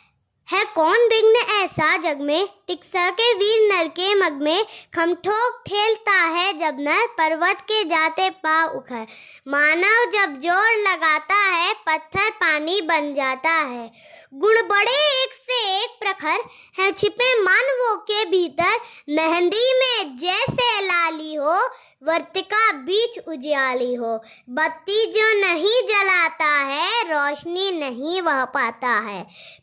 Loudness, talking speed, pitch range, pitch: -18 LUFS, 125 wpm, 310-425 Hz, 360 Hz